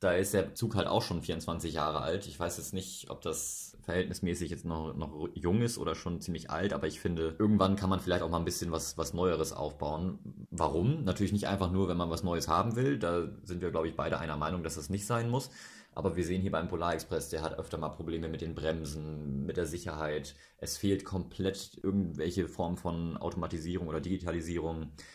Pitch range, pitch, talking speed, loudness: 80-95 Hz, 85 Hz, 215 wpm, -34 LUFS